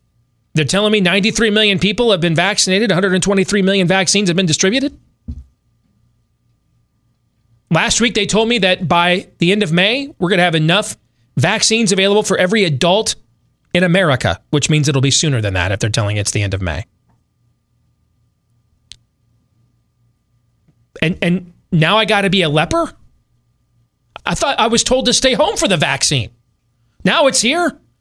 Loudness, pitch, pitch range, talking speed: -14 LUFS, 155 Hz, 120-195 Hz, 165 wpm